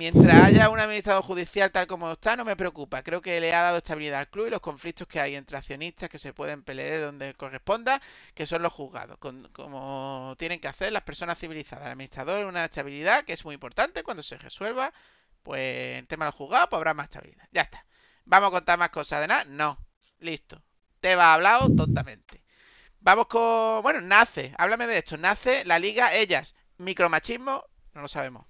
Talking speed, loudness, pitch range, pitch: 200 wpm, -24 LUFS, 145-195 Hz, 170 Hz